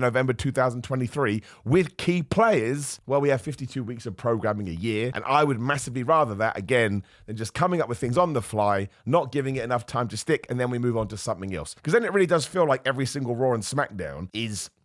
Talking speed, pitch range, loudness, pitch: 235 wpm, 110-145 Hz, -25 LUFS, 125 Hz